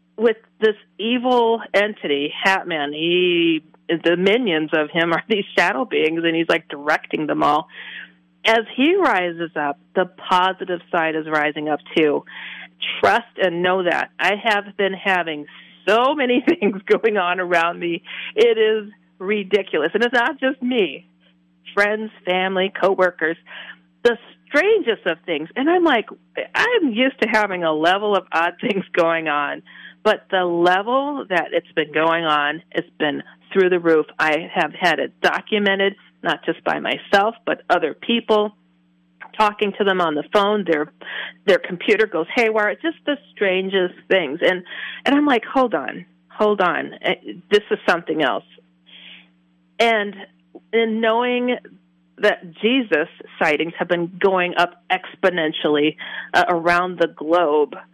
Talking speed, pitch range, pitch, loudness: 150 wpm, 165-215 Hz, 185 Hz, -19 LUFS